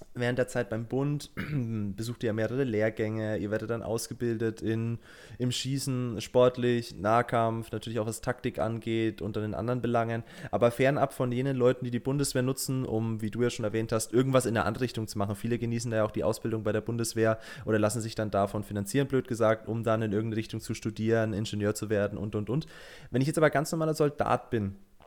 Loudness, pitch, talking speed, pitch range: -30 LUFS, 115 Hz, 215 wpm, 110-125 Hz